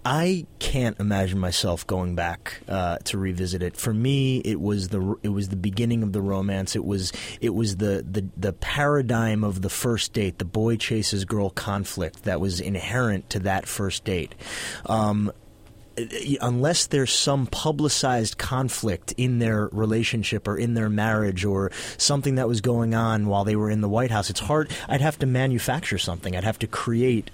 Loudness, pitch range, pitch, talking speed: -25 LUFS, 100-120 Hz, 105 Hz, 185 wpm